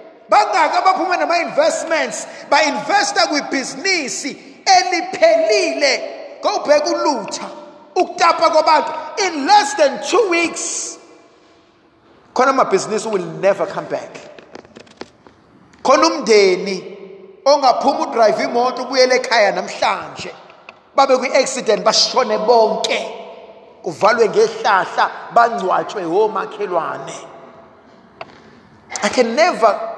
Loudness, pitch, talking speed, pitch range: -16 LUFS, 290 Hz, 100 wpm, 230-340 Hz